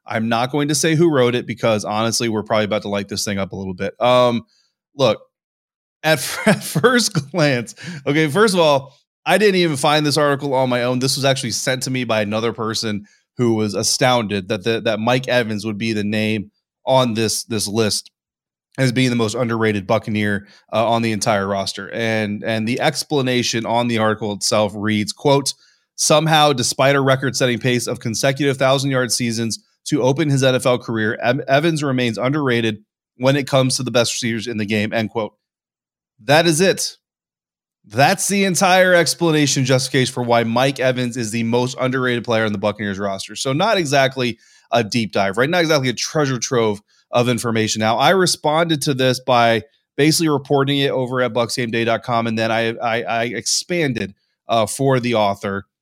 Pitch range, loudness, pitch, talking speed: 110-140 Hz, -18 LUFS, 125 Hz, 190 wpm